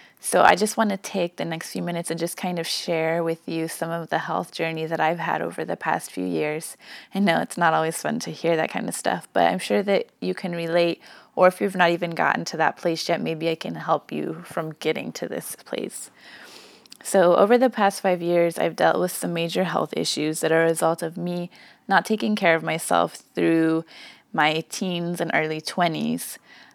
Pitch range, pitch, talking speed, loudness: 165-185 Hz, 170 Hz, 220 wpm, -23 LUFS